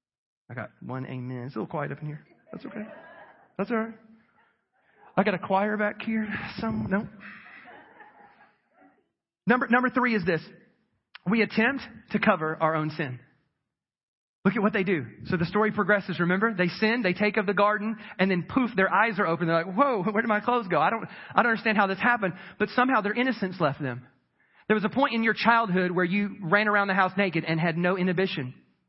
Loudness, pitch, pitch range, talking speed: -26 LUFS, 205 Hz, 175-220 Hz, 210 wpm